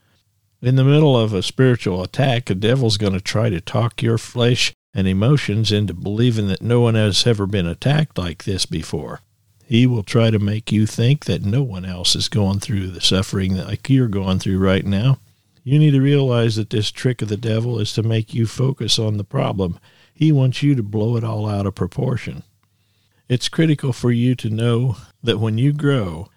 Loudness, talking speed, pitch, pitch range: -19 LUFS, 205 wpm, 110 Hz, 100-125 Hz